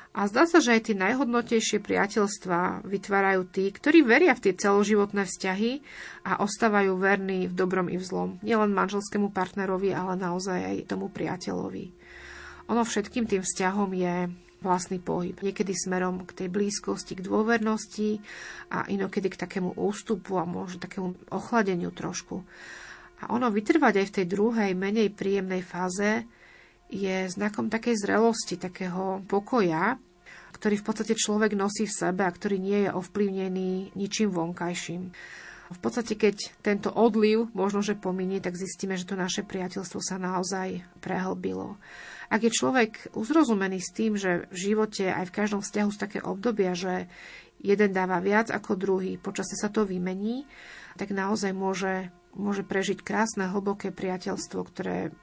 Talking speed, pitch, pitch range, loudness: 150 wpm, 195 Hz, 185-210 Hz, -27 LUFS